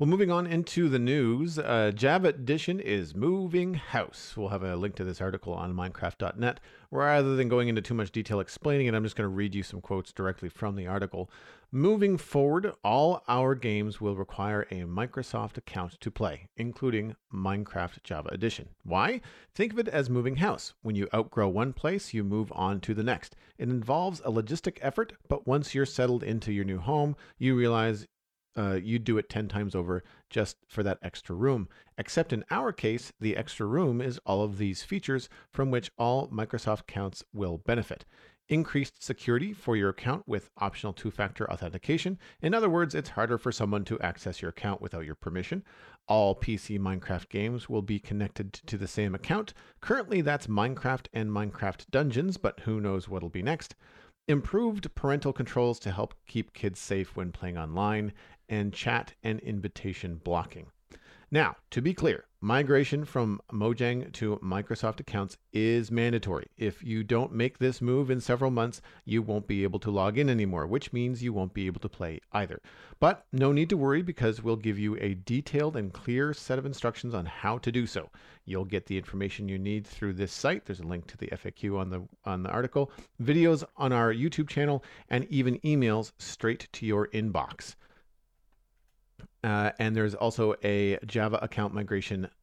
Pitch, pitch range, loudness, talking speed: 110 Hz, 100-130 Hz, -30 LUFS, 185 wpm